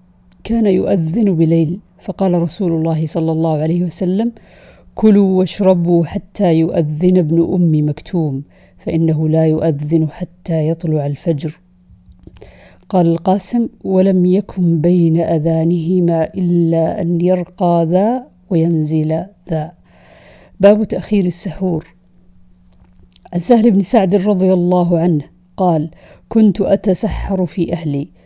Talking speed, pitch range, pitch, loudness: 105 wpm, 160-190 Hz, 170 Hz, -15 LUFS